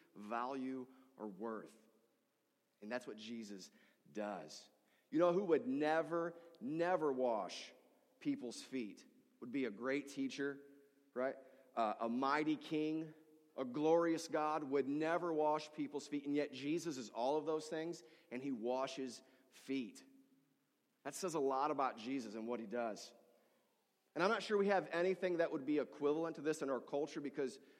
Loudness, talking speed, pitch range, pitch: -41 LUFS, 160 wpm, 130-165 Hz, 145 Hz